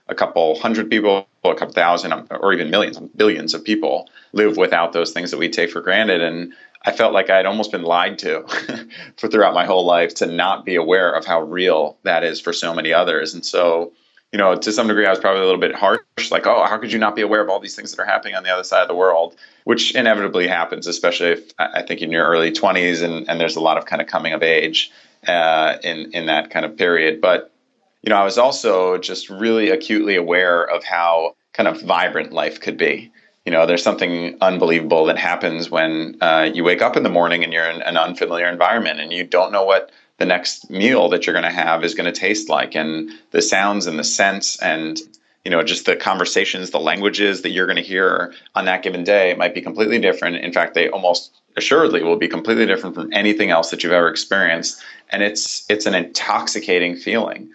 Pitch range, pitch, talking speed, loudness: 85-105 Hz, 90 Hz, 230 wpm, -17 LUFS